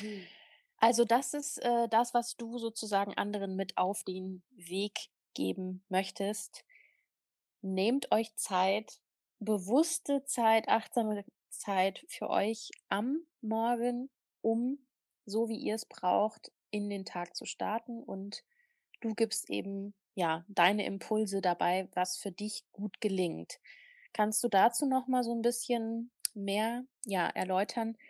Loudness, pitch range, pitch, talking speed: -33 LUFS, 195-240 Hz, 220 Hz, 130 wpm